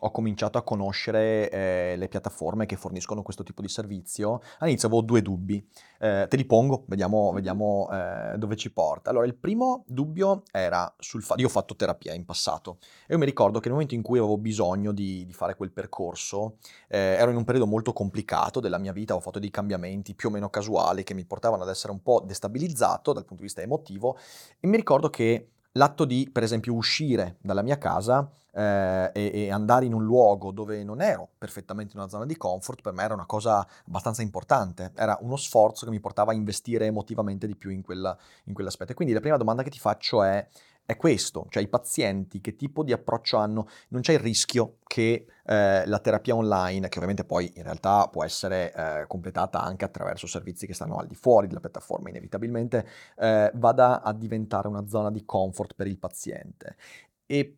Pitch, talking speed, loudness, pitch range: 110 Hz, 205 wpm, -27 LUFS, 100-120 Hz